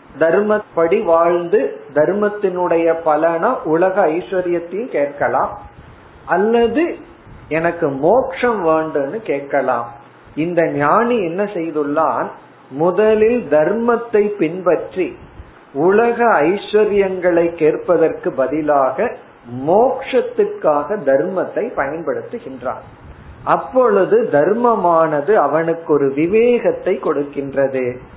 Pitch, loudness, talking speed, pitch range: 170 Hz, -16 LUFS, 70 wpm, 150-225 Hz